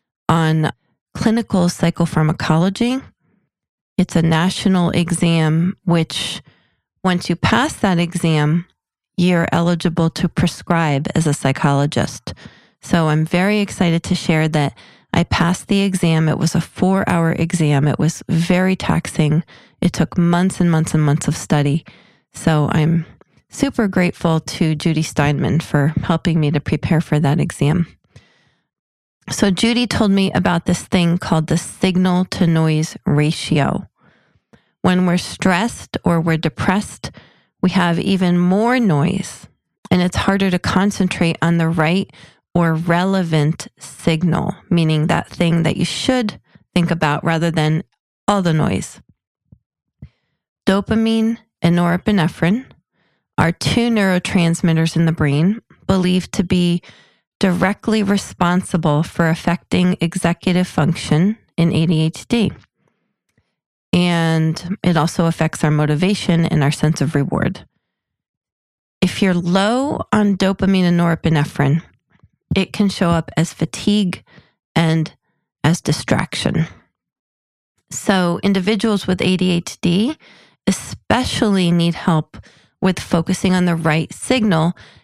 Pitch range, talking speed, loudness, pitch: 160-190 Hz, 120 wpm, -17 LUFS, 175 Hz